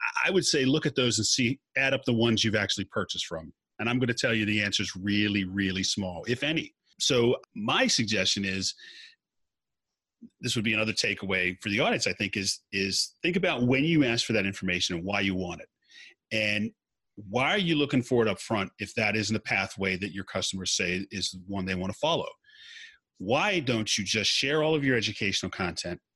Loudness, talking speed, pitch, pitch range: -27 LUFS, 215 wpm, 110 Hz, 95-135 Hz